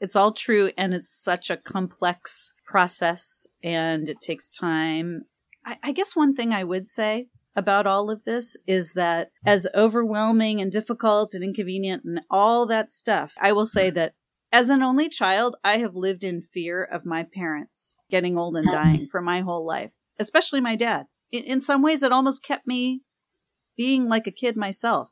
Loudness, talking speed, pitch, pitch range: -23 LUFS, 185 wpm, 200 Hz, 180-235 Hz